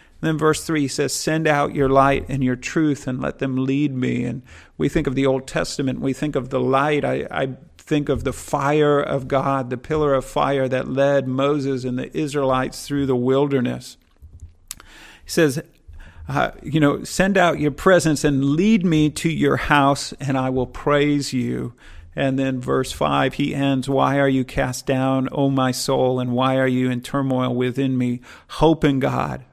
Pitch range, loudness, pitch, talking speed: 130-145 Hz, -20 LUFS, 135 Hz, 195 wpm